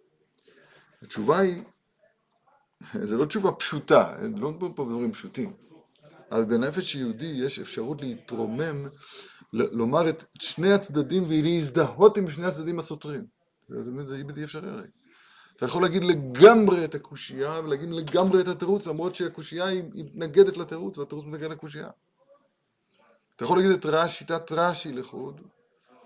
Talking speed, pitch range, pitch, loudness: 135 wpm, 150-190 Hz, 165 Hz, -25 LUFS